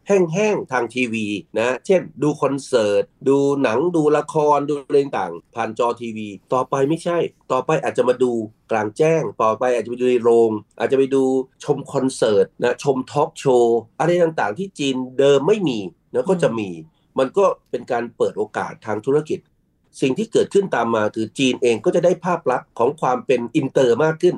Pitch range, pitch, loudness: 120-165 Hz, 135 Hz, -20 LUFS